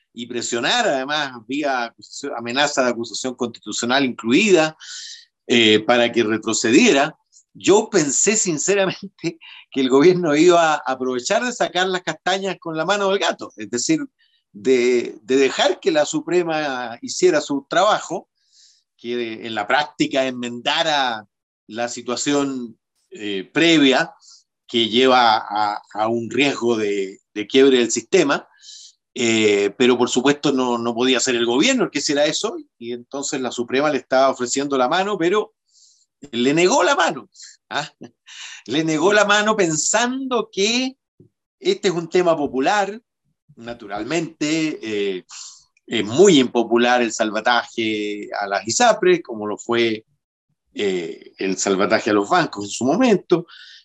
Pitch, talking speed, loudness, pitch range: 135 Hz, 140 wpm, -19 LUFS, 120-185 Hz